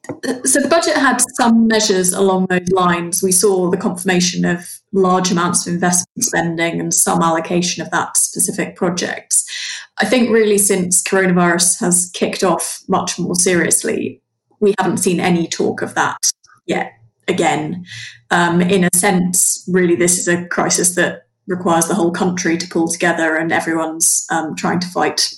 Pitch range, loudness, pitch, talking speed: 175-195 Hz, -15 LUFS, 180 Hz, 165 wpm